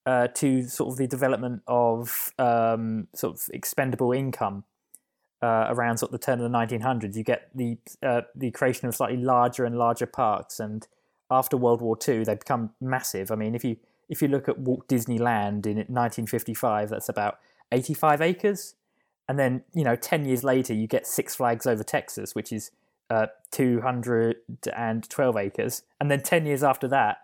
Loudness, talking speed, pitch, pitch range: -26 LUFS, 180 wpm, 120 Hz, 115-130 Hz